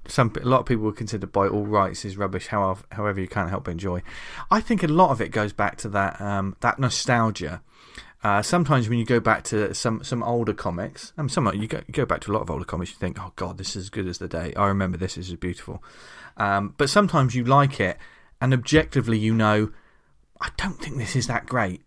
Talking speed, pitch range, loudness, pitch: 250 wpm, 95-120 Hz, -24 LUFS, 105 Hz